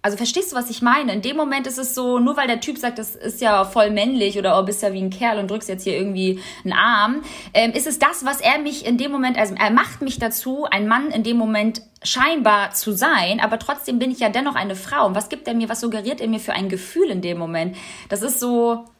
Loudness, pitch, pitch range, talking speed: -20 LUFS, 230 Hz, 205-265 Hz, 265 wpm